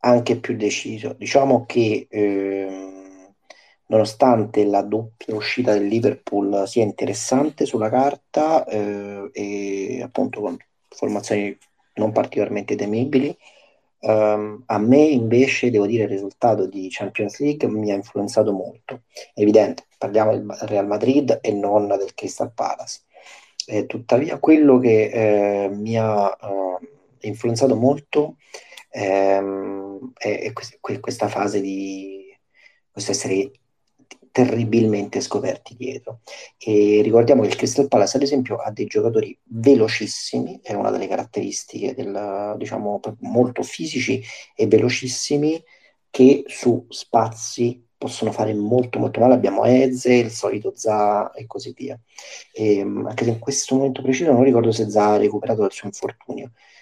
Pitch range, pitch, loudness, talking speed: 100-125 Hz, 110 Hz, -20 LUFS, 130 wpm